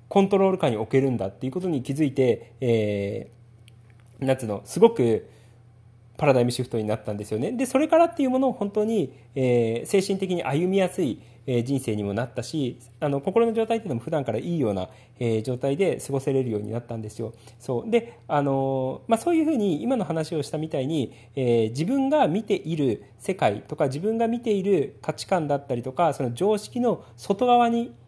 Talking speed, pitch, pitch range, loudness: 395 characters per minute, 135 Hz, 120-195 Hz, -25 LUFS